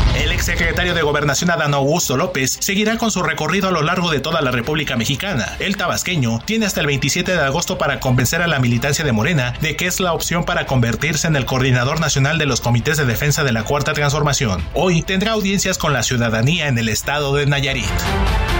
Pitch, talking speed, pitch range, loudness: 145 Hz, 210 wpm, 130-170 Hz, -17 LUFS